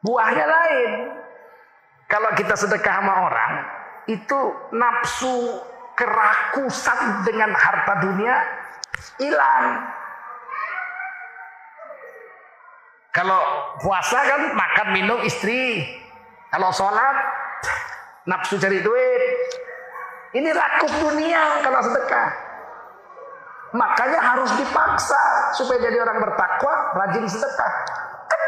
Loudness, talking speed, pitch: -20 LUFS, 80 wpm, 275 Hz